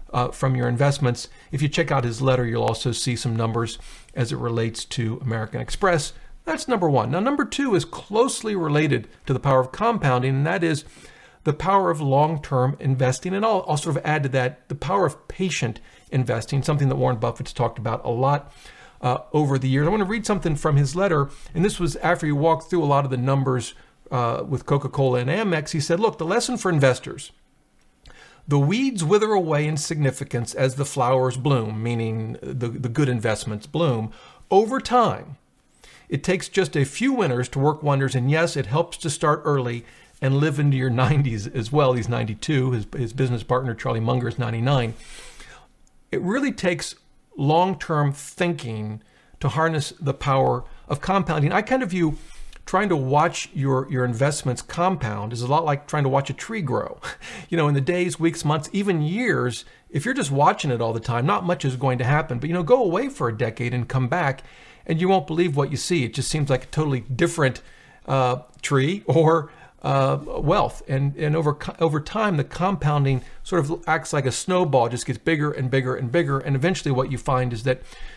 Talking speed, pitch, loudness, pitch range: 205 wpm, 140 Hz, -23 LUFS, 125-165 Hz